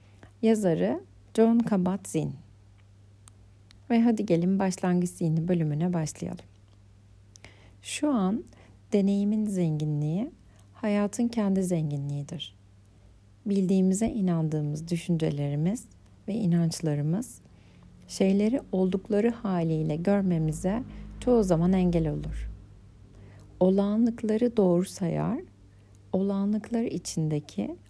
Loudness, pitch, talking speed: -27 LUFS, 165 Hz, 75 wpm